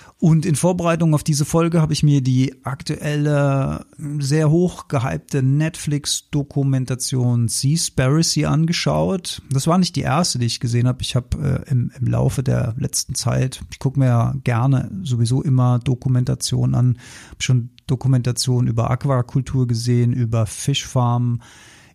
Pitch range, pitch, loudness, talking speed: 120-150 Hz, 130 Hz, -19 LUFS, 140 wpm